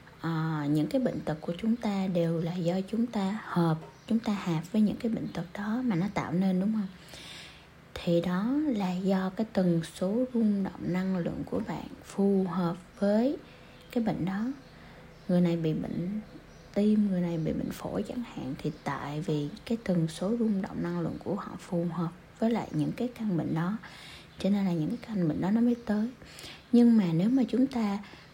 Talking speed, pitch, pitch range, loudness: 210 wpm, 190 Hz, 170-220 Hz, -30 LUFS